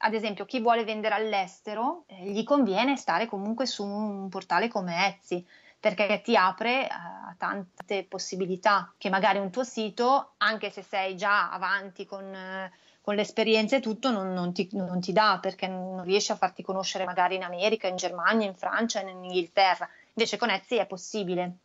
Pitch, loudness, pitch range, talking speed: 200 Hz, -28 LUFS, 190-220 Hz, 180 wpm